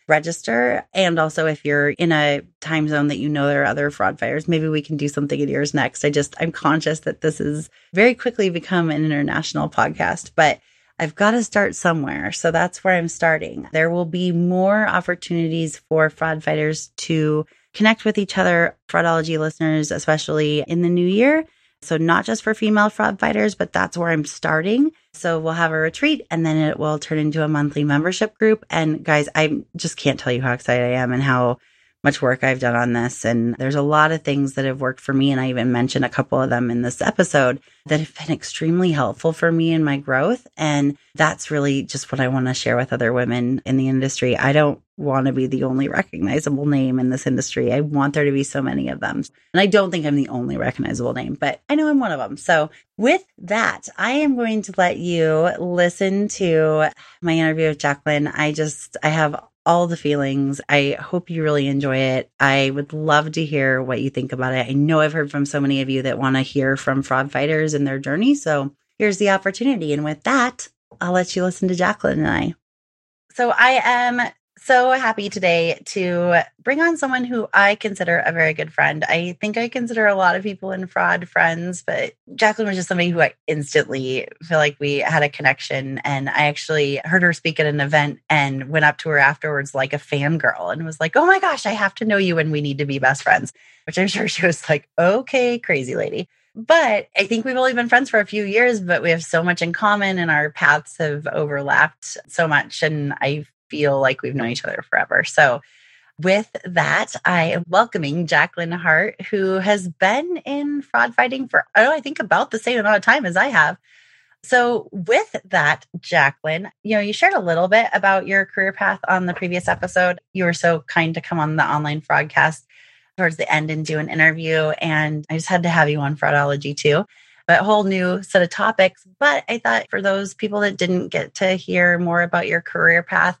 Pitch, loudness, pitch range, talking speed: 160 Hz, -19 LUFS, 145-190 Hz, 220 wpm